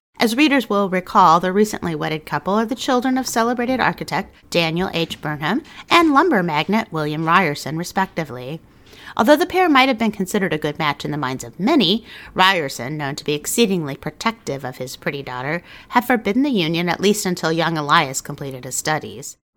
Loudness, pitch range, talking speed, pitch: -19 LUFS, 150-230 Hz, 185 wpm, 175 Hz